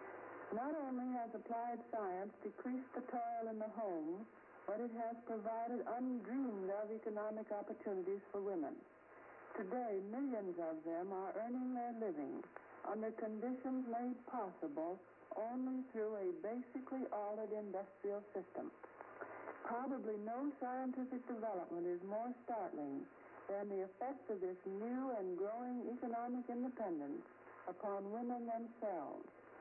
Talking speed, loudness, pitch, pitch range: 120 wpm, -45 LUFS, 230 Hz, 205-255 Hz